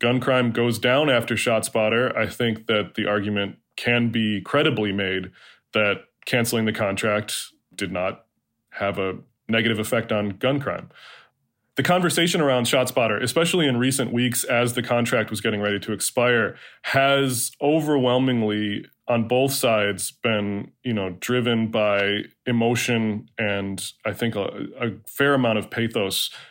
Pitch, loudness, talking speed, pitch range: 115 Hz, -22 LUFS, 145 wpm, 105-125 Hz